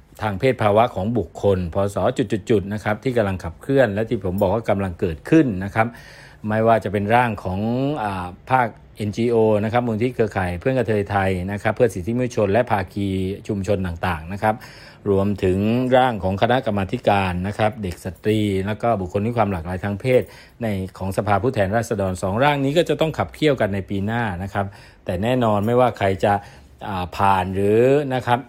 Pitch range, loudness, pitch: 95-120 Hz, -21 LUFS, 105 Hz